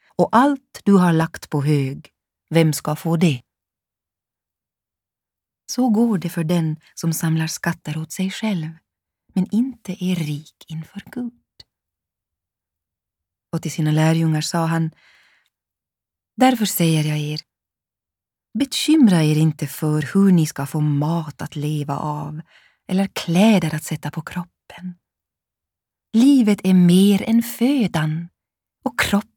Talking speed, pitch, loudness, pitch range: 130 wpm, 160 Hz, -19 LUFS, 150-190 Hz